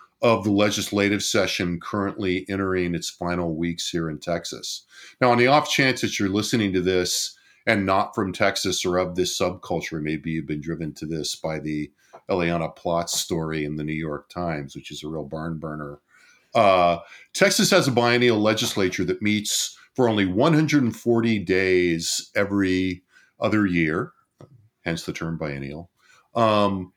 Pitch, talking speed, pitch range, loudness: 90 Hz, 160 wpm, 80-105 Hz, -23 LUFS